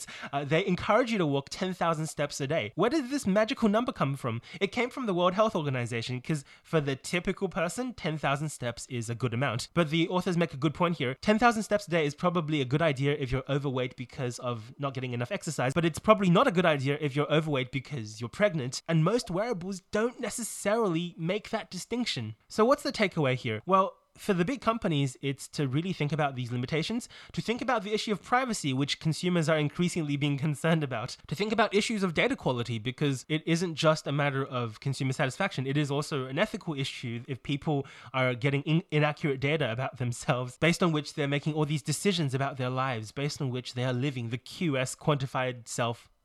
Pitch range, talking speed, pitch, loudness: 135-185 Hz, 215 wpm, 155 Hz, -29 LUFS